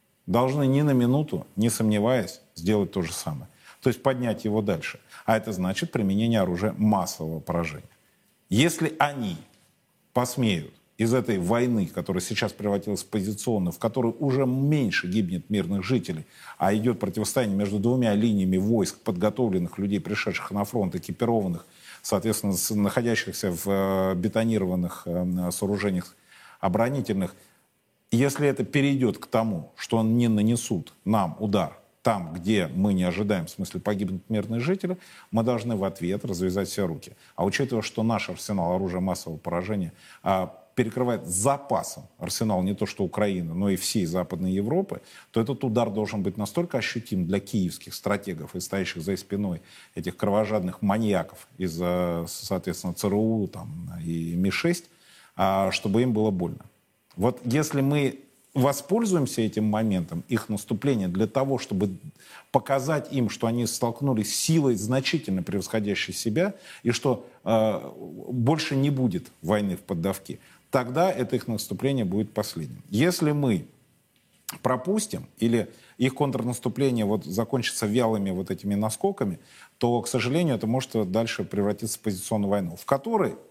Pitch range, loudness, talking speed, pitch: 100-130 Hz, -26 LUFS, 140 wpm, 110 Hz